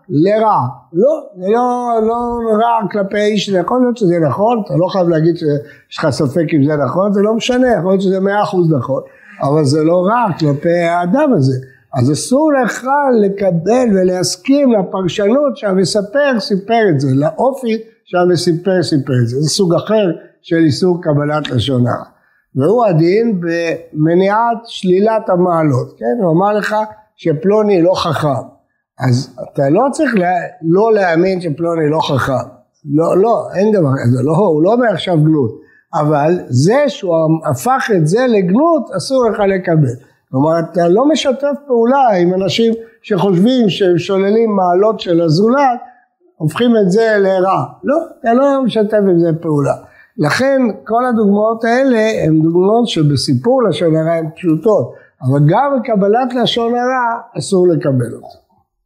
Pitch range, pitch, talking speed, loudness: 160-230 Hz, 190 Hz, 150 wpm, -13 LUFS